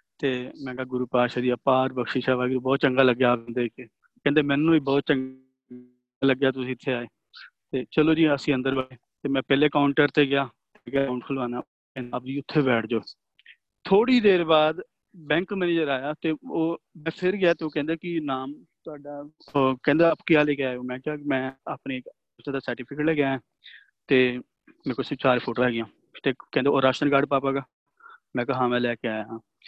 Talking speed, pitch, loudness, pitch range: 200 wpm, 135 Hz, -25 LUFS, 125-150 Hz